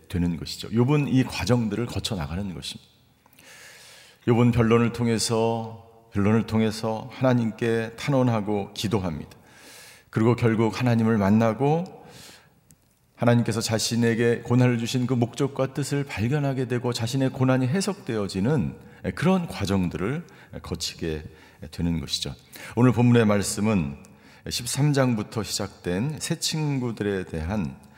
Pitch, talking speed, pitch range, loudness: 115 Hz, 285 characters per minute, 100-125 Hz, -24 LUFS